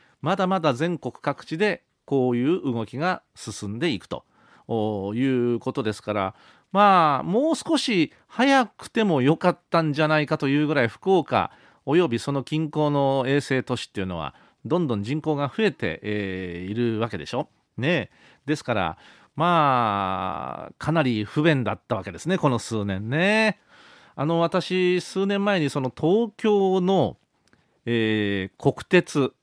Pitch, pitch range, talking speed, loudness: 140 Hz, 115-180 Hz, 265 characters per minute, -24 LUFS